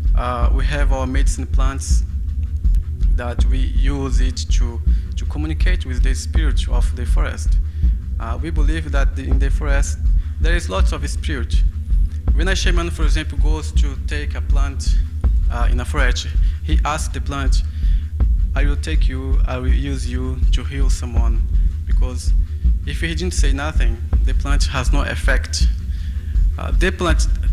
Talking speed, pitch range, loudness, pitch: 160 wpm, 70-80 Hz, -20 LUFS, 75 Hz